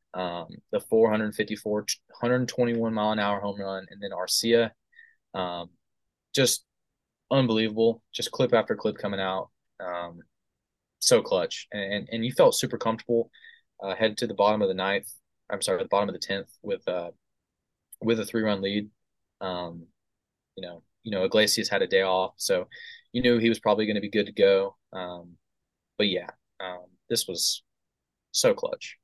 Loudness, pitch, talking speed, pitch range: -26 LUFS, 110 Hz, 175 wpm, 95-120 Hz